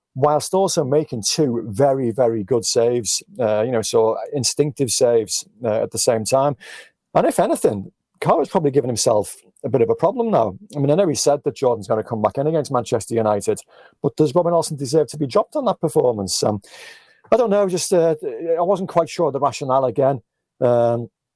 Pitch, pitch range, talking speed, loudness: 140 Hz, 115-160 Hz, 210 wpm, -19 LUFS